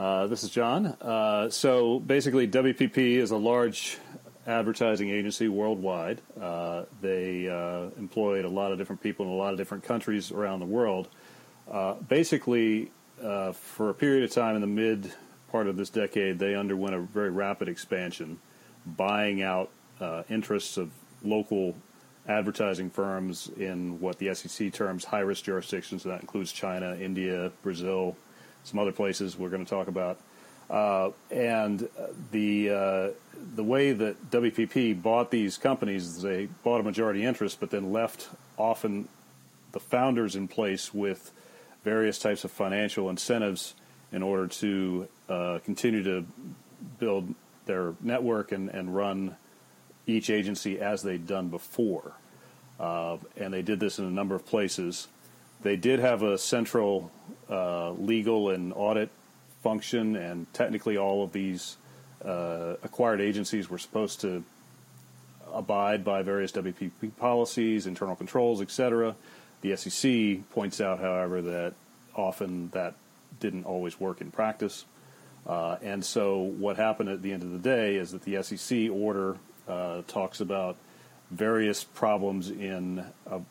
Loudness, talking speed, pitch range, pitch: -30 LUFS, 145 wpm, 95-110 Hz, 100 Hz